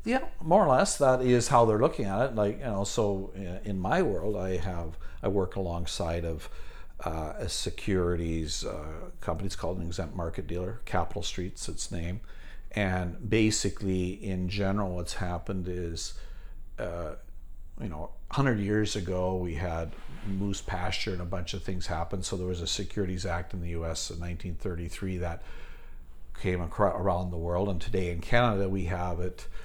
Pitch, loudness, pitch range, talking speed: 90 Hz, -31 LUFS, 85-100 Hz, 170 wpm